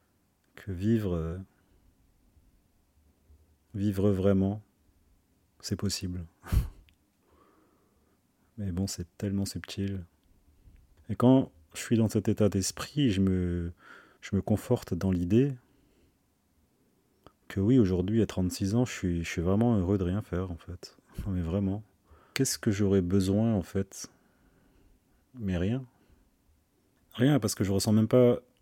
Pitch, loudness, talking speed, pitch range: 95 Hz, -29 LUFS, 130 wpm, 90-105 Hz